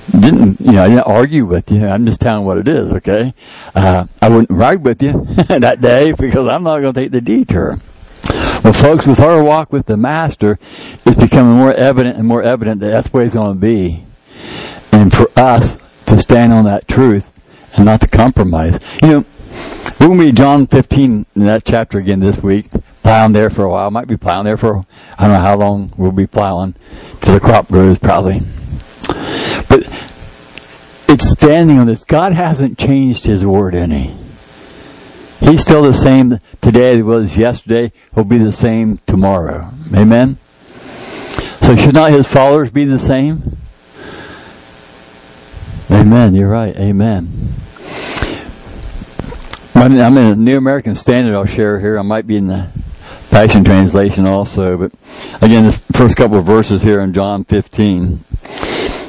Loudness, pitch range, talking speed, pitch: -10 LUFS, 95-125 Hz, 170 wpm, 110 Hz